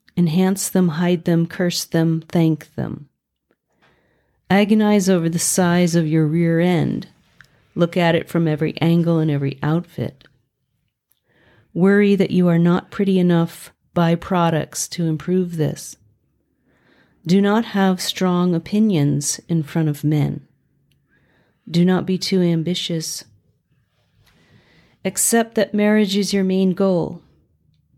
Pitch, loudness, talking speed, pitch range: 170 Hz, -18 LUFS, 125 wpm, 160-185 Hz